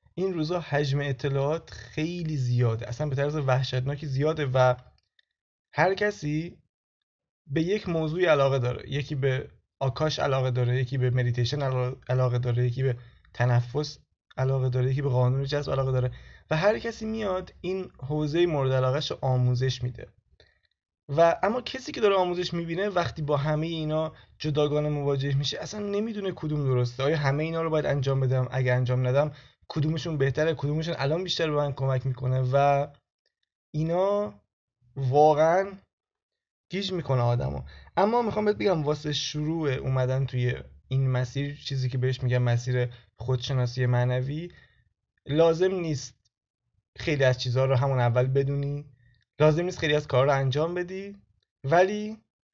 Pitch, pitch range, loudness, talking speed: 140 Hz, 125-160 Hz, -27 LUFS, 145 wpm